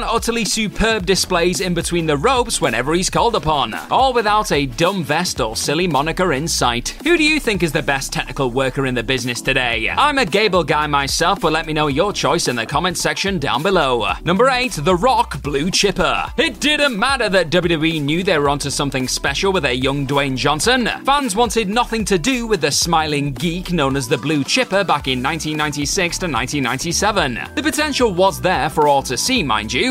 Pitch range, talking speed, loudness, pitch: 145-210 Hz, 205 wpm, -17 LUFS, 170 Hz